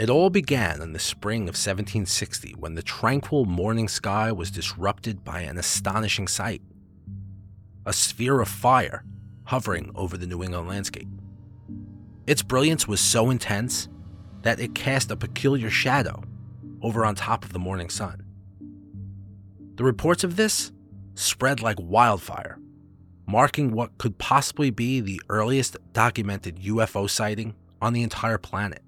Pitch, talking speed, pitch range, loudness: 105 Hz, 140 wpm, 100-115 Hz, -24 LUFS